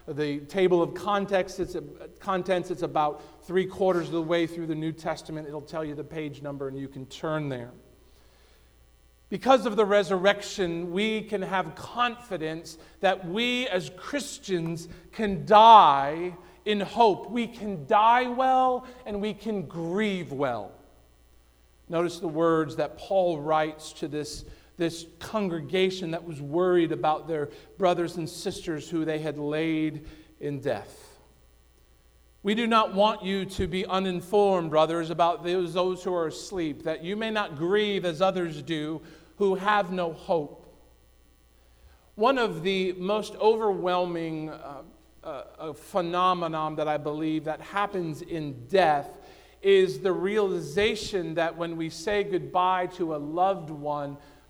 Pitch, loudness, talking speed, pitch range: 170 Hz, -26 LUFS, 145 wpm, 155-195 Hz